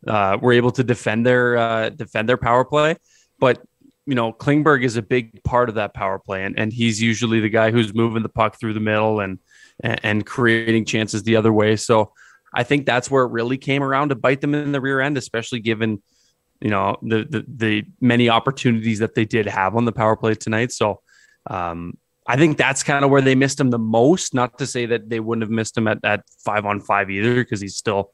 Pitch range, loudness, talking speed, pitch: 110-125 Hz, -19 LUFS, 230 wpm, 115 Hz